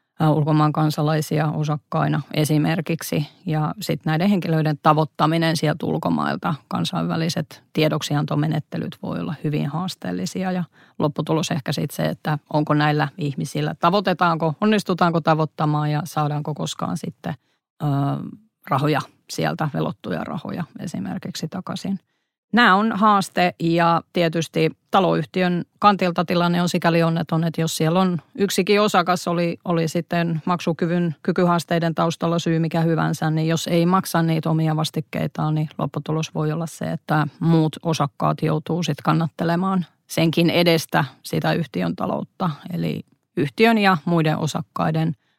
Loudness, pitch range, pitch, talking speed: -21 LUFS, 155-175 Hz, 165 Hz, 125 wpm